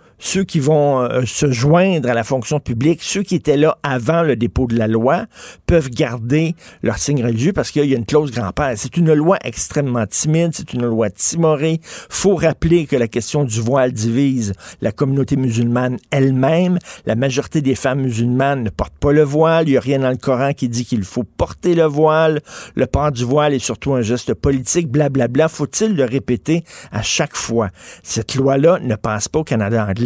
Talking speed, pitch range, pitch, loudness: 205 wpm, 120-155 Hz, 135 Hz, -17 LUFS